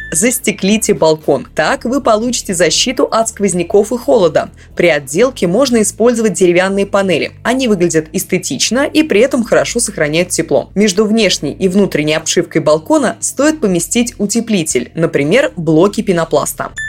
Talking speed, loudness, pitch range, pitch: 130 wpm, -12 LUFS, 175-240 Hz, 205 Hz